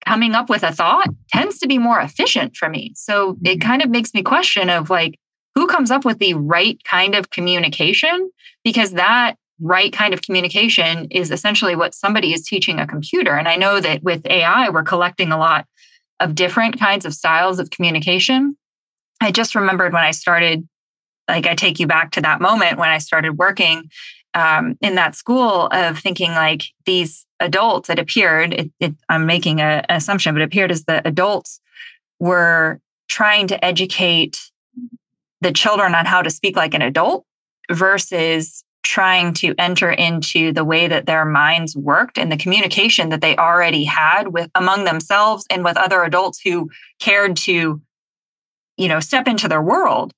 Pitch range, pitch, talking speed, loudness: 165-205 Hz, 180 Hz, 180 wpm, -15 LUFS